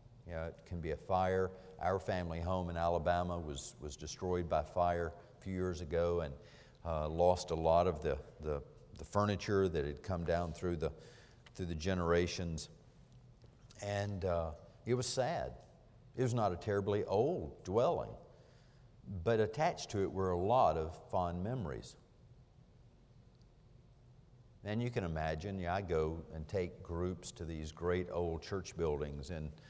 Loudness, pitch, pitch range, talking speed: -37 LUFS, 90 Hz, 85-110 Hz, 160 wpm